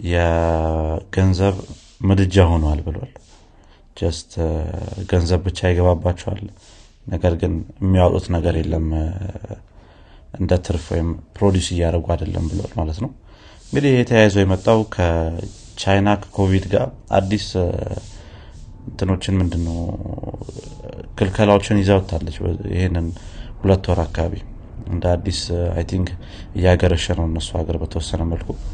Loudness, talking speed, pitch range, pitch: -20 LUFS, 100 wpm, 85-100 Hz, 90 Hz